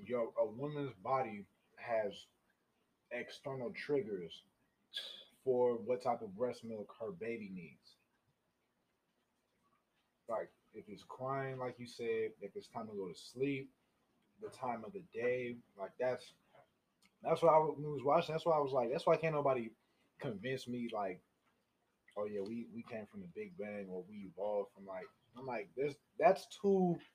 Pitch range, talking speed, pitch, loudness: 115-165 Hz, 160 wpm, 130 Hz, -39 LUFS